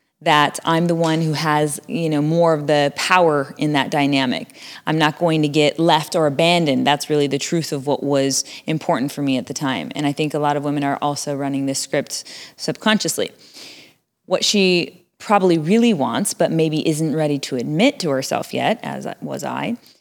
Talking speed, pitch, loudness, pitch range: 200 wpm, 150 Hz, -19 LUFS, 145-170 Hz